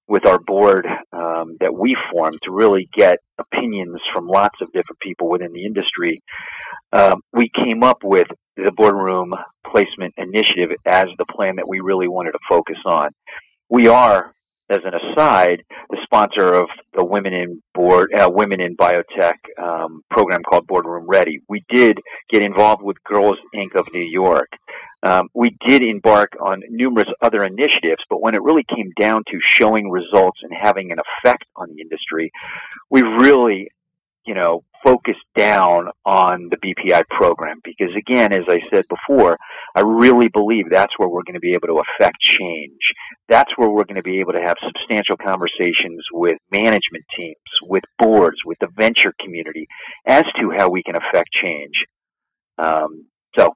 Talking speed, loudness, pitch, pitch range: 170 wpm, -16 LUFS, 95 Hz, 90-110 Hz